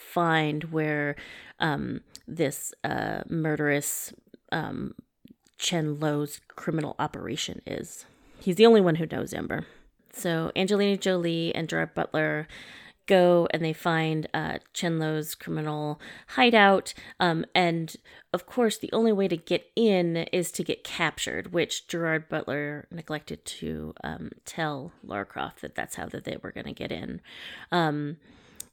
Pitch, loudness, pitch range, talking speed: 165 Hz, -27 LUFS, 150-180 Hz, 140 wpm